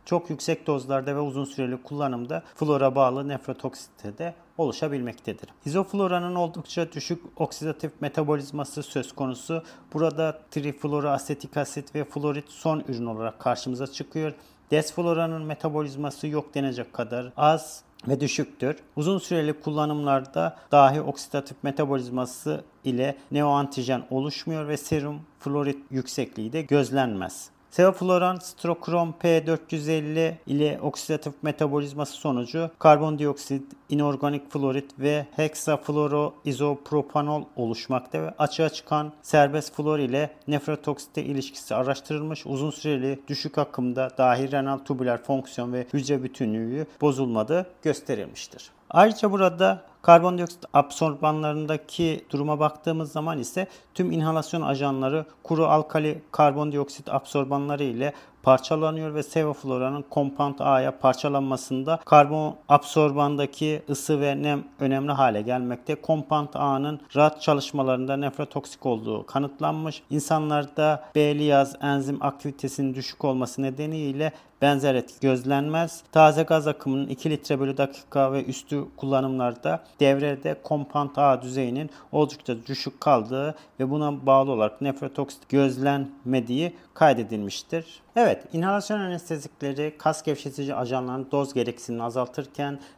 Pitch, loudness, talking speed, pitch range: 145 Hz, -25 LUFS, 110 wpm, 135-155 Hz